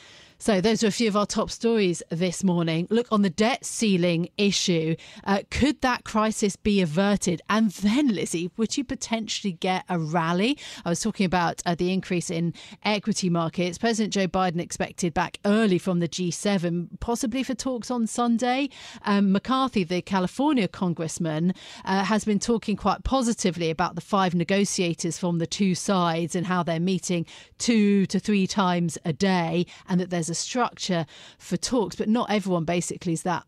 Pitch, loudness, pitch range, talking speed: 195 Hz, -25 LUFS, 175-220 Hz, 175 wpm